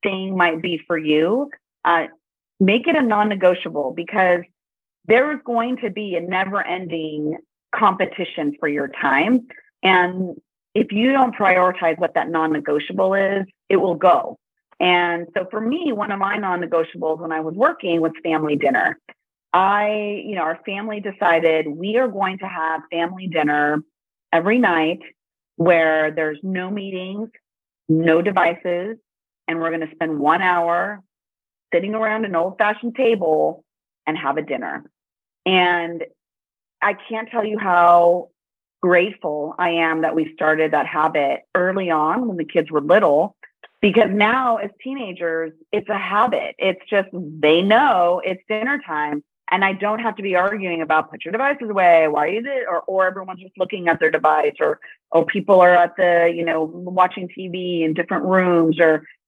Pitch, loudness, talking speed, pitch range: 180 Hz, -19 LUFS, 165 wpm, 165-205 Hz